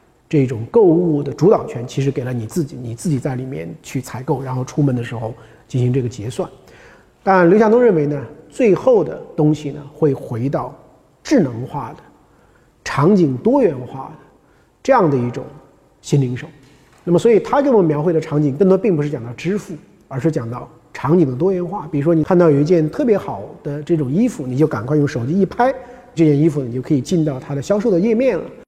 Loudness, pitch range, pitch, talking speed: -17 LUFS, 130-175 Hz, 150 Hz, 310 characters per minute